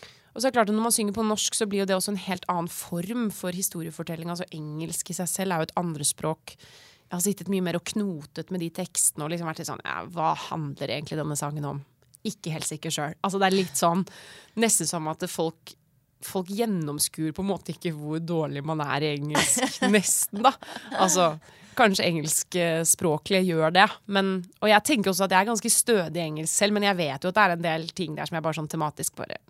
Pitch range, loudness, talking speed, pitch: 155-195 Hz, -25 LUFS, 225 wpm, 175 Hz